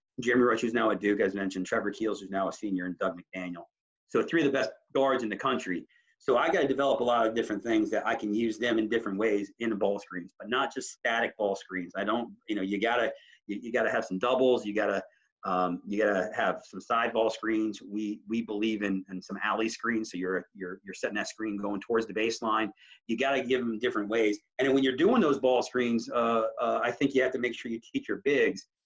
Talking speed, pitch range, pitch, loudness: 250 wpm, 105-125 Hz, 110 Hz, -29 LUFS